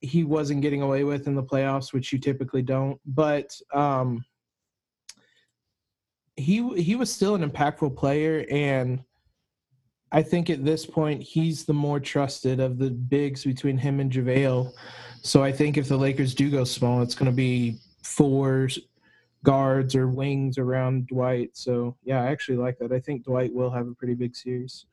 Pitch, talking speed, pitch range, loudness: 135 Hz, 175 wpm, 125-145 Hz, -25 LUFS